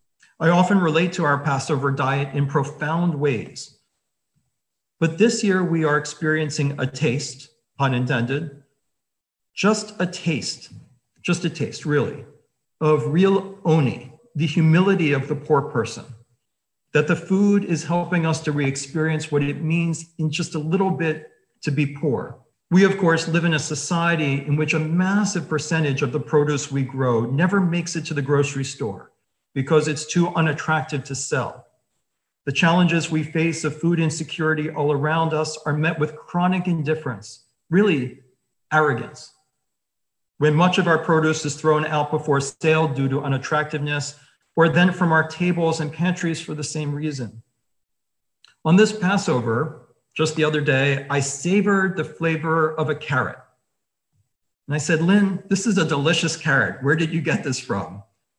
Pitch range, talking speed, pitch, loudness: 140-165 Hz, 160 wpm, 155 Hz, -21 LUFS